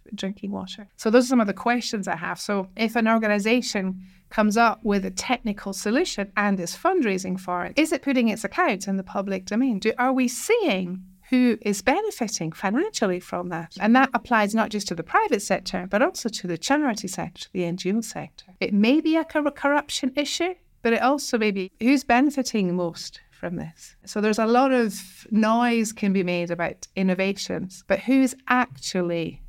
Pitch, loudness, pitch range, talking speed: 215 Hz, -23 LUFS, 190-250 Hz, 190 wpm